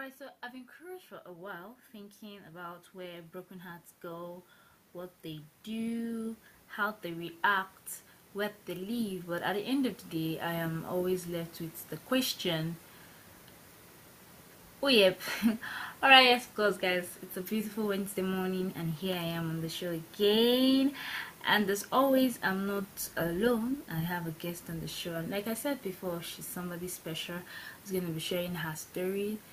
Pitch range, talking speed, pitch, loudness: 175-215 Hz, 175 wpm, 185 Hz, -31 LUFS